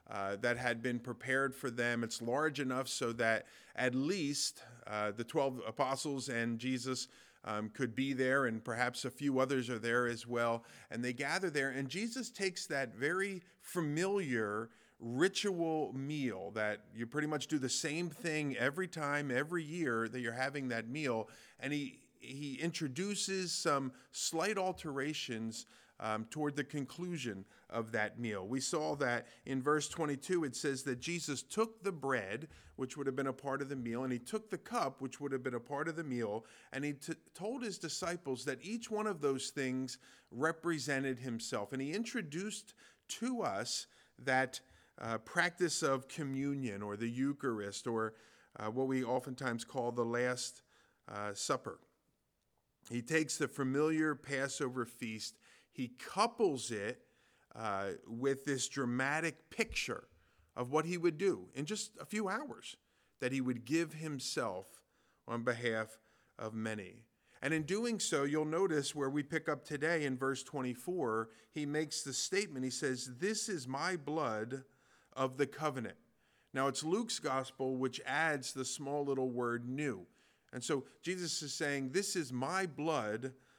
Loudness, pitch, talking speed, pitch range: -38 LUFS, 135 Hz, 165 wpm, 125-160 Hz